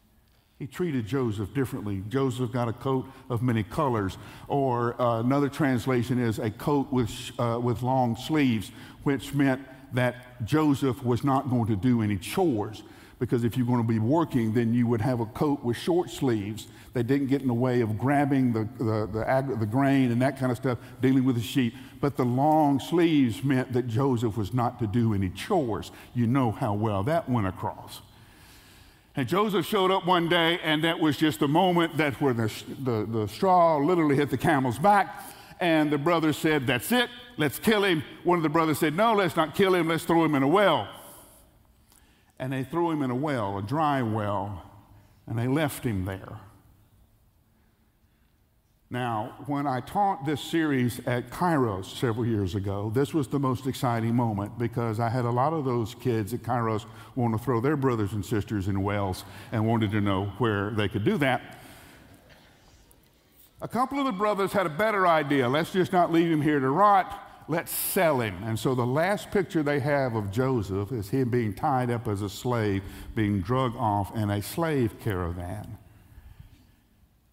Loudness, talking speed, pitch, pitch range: -26 LUFS, 190 wpm, 125 Hz, 110-145 Hz